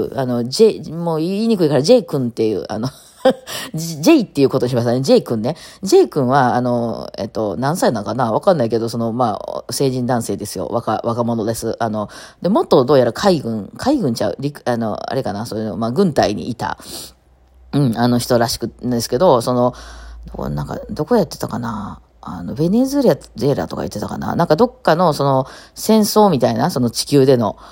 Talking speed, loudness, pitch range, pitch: 365 characters per minute, -17 LUFS, 115-160 Hz, 125 Hz